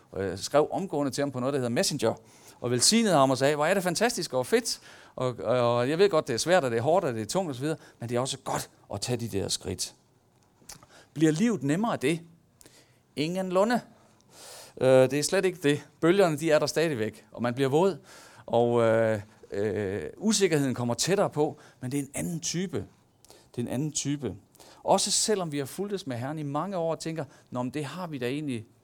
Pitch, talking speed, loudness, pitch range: 145 Hz, 225 wpm, -27 LUFS, 120-170 Hz